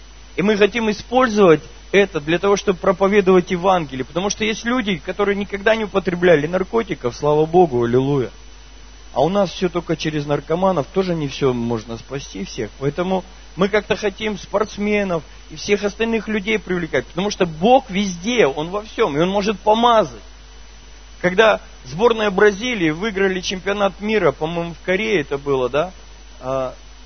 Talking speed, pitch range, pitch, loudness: 150 wpm, 150-205 Hz, 185 Hz, -19 LUFS